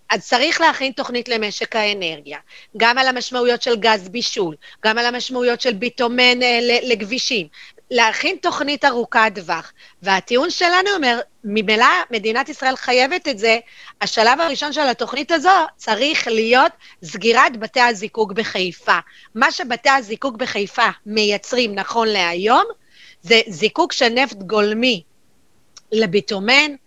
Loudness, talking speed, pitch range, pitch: -17 LUFS, 125 wpm, 215-260 Hz, 235 Hz